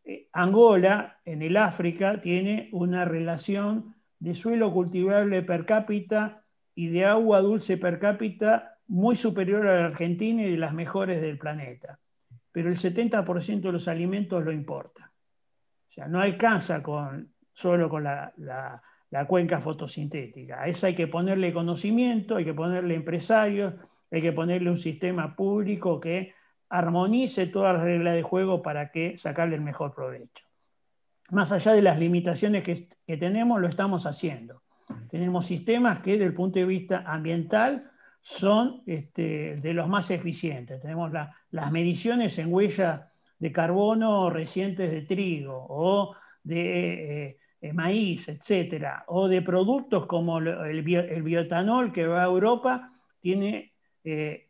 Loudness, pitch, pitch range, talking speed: -26 LUFS, 180 Hz, 165-200 Hz, 150 wpm